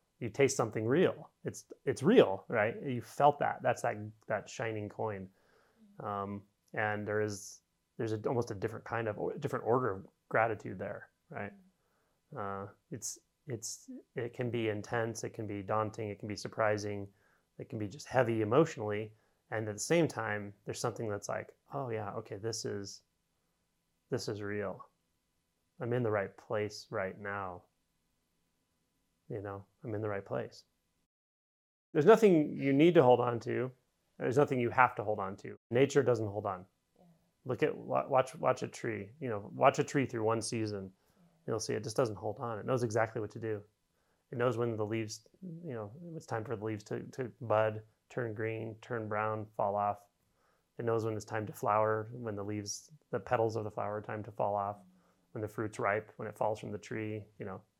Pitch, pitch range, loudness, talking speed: 110 Hz, 100-120 Hz, -34 LUFS, 195 wpm